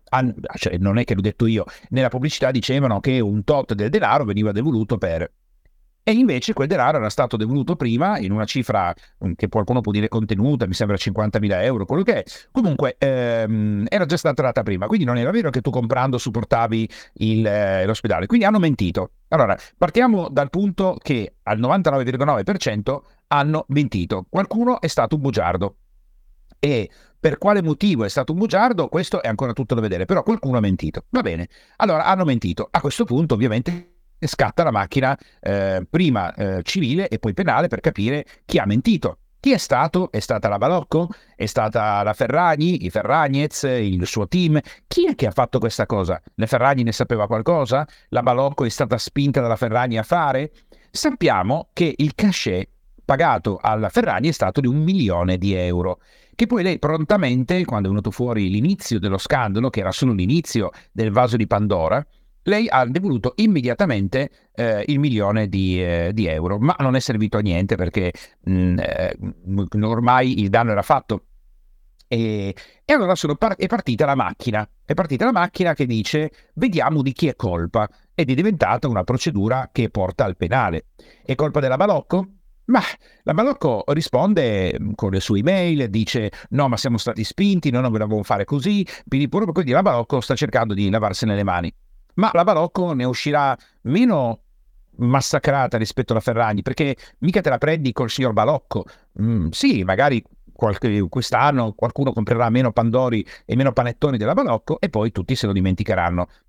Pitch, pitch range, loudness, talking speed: 125 Hz, 105-150 Hz, -20 LUFS, 175 wpm